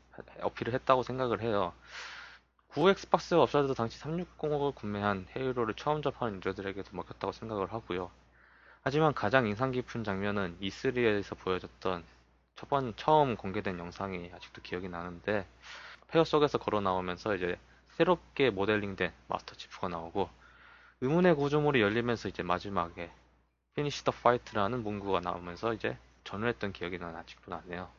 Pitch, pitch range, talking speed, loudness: 100 Hz, 90-130 Hz, 355 characters per minute, -32 LUFS